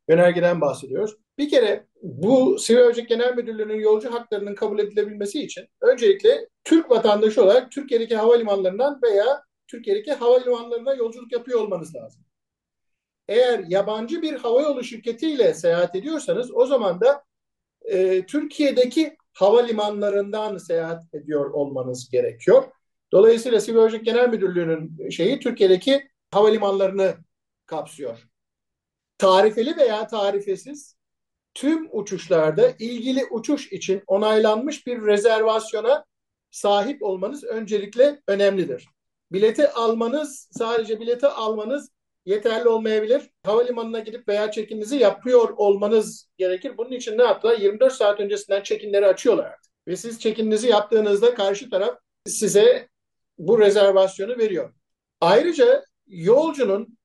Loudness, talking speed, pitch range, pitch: -21 LUFS, 110 wpm, 205-280 Hz, 230 Hz